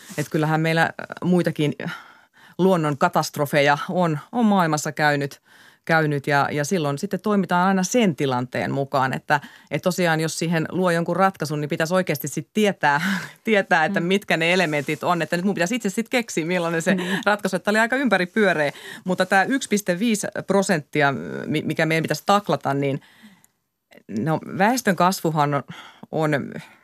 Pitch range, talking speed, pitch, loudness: 150-195 Hz, 155 wpm, 180 Hz, -21 LUFS